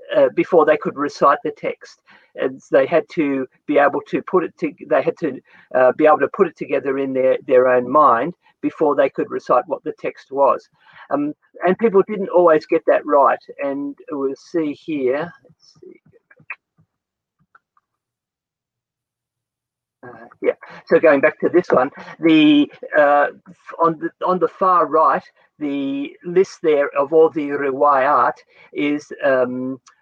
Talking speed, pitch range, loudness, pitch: 160 wpm, 135-190 Hz, -18 LUFS, 150 Hz